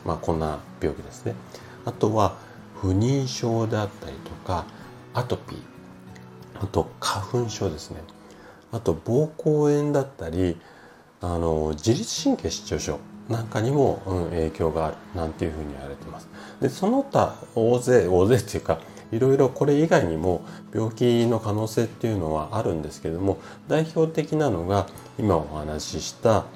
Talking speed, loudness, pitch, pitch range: 280 characters per minute, -25 LUFS, 100 Hz, 80-120 Hz